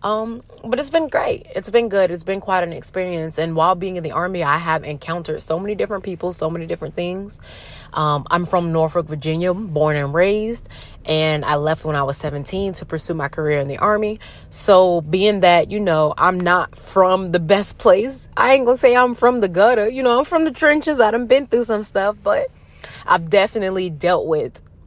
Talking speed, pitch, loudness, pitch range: 210 wpm, 185 Hz, -18 LUFS, 160-215 Hz